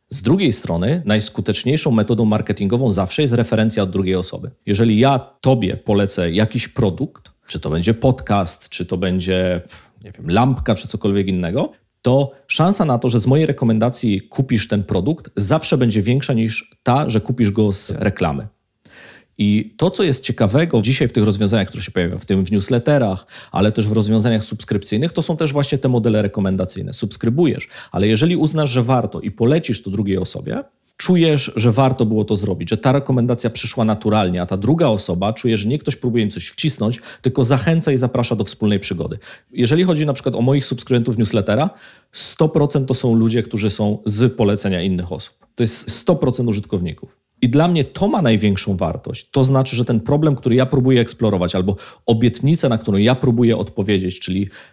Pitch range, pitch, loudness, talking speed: 105-135 Hz, 115 Hz, -18 LUFS, 185 wpm